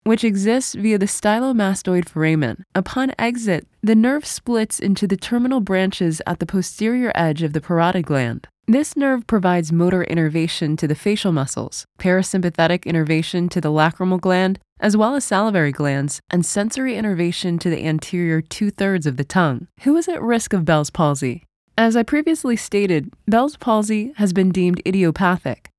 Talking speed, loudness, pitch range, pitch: 165 wpm, -19 LUFS, 165-220 Hz, 185 Hz